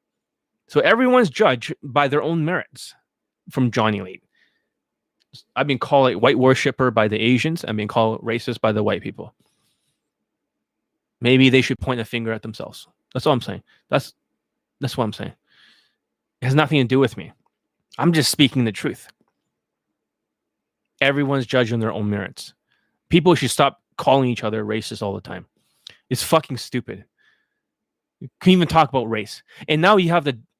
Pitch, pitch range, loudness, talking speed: 130 Hz, 110-155 Hz, -19 LUFS, 165 wpm